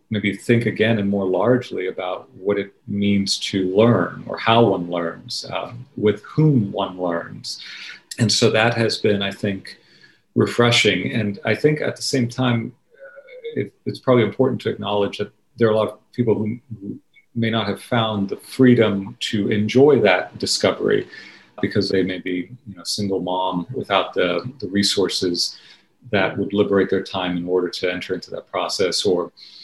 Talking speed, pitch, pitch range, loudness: 170 wpm, 105 Hz, 100-120 Hz, -20 LUFS